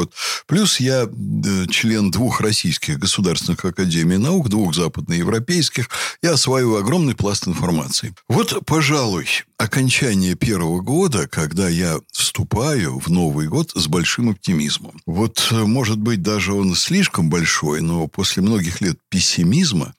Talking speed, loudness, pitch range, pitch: 130 wpm, -18 LUFS, 95-130 Hz, 110 Hz